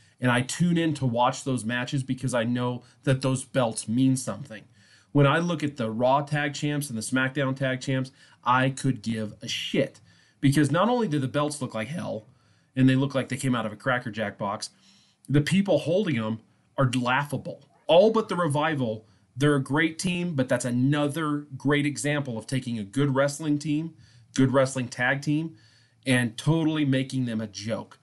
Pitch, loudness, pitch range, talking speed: 130 Hz, -26 LUFS, 120-145 Hz, 195 wpm